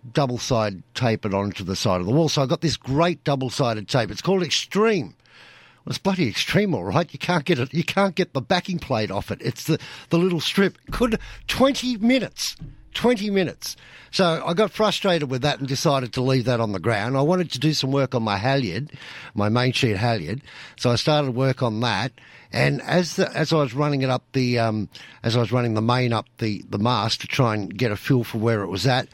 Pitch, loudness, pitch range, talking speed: 135 Hz, -22 LUFS, 120-170 Hz, 235 wpm